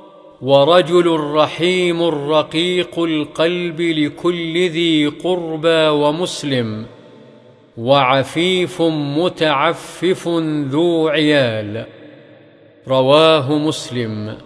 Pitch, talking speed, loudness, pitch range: 155 Hz, 60 wpm, -16 LUFS, 140-170 Hz